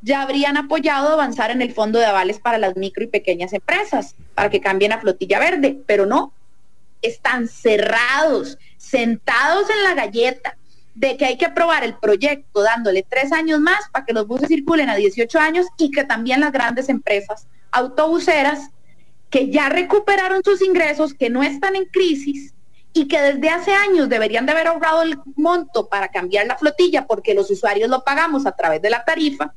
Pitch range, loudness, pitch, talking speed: 225-320 Hz, -17 LUFS, 280 Hz, 185 wpm